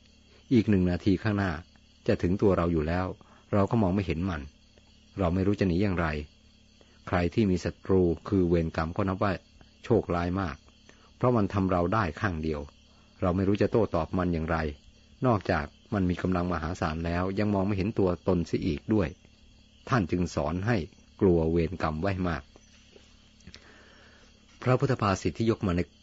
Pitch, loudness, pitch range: 90 Hz, -28 LUFS, 80-100 Hz